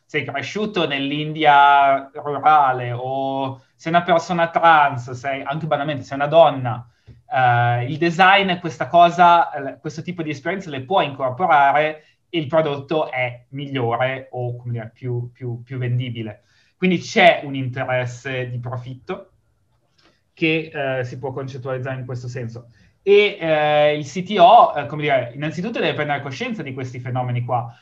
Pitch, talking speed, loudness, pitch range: 140 Hz, 145 wpm, -19 LUFS, 125-160 Hz